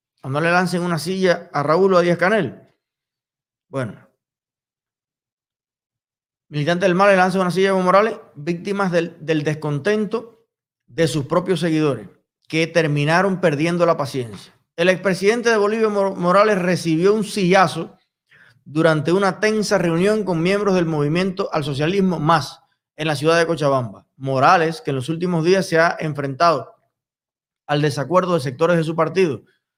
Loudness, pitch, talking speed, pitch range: -18 LUFS, 170 Hz, 150 wpm, 150-190 Hz